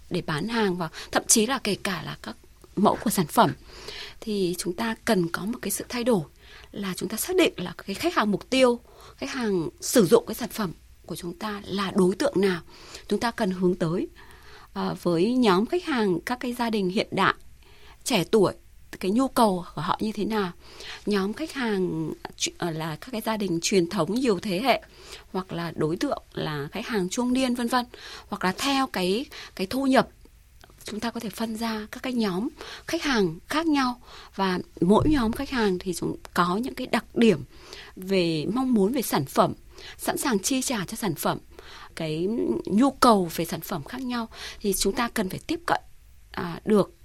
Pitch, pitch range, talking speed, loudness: 210 Hz, 180-245 Hz, 205 wpm, -26 LUFS